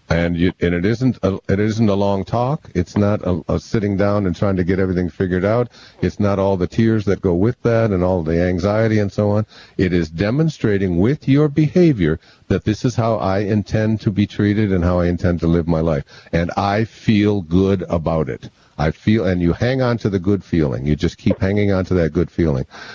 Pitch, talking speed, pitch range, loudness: 100 Hz, 230 wpm, 90-110 Hz, -18 LUFS